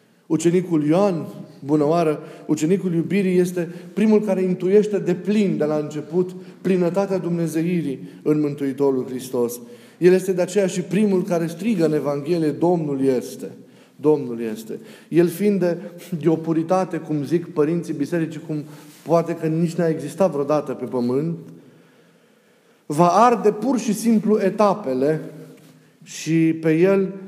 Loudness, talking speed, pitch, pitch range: -21 LUFS, 135 wpm, 170 Hz, 150-185 Hz